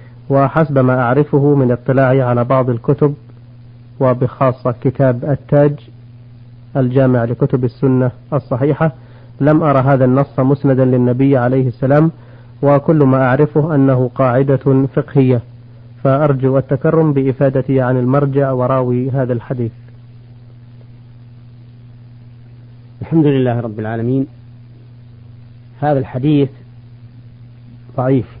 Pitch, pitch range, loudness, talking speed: 130 Hz, 120-135 Hz, -14 LUFS, 95 wpm